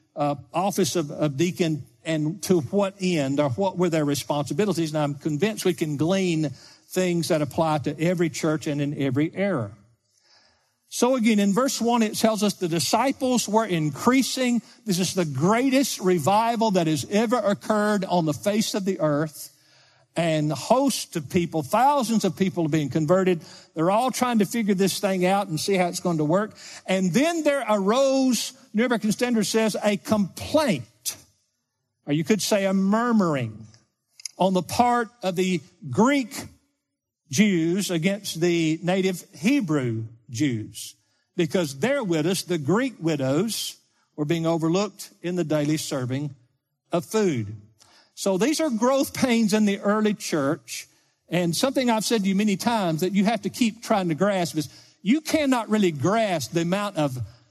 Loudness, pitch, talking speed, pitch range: -24 LUFS, 180 Hz, 170 wpm, 155-215 Hz